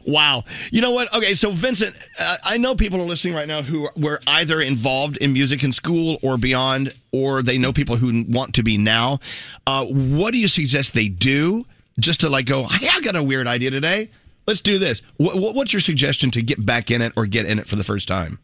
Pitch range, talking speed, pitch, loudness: 125-175 Hz, 230 wpm, 140 Hz, -19 LUFS